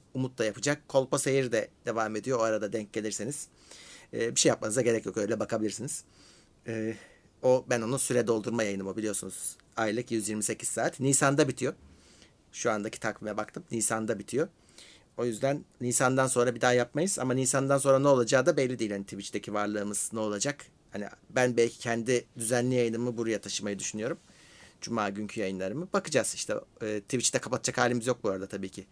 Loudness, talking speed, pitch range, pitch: -29 LUFS, 165 wpm, 105-130 Hz, 115 Hz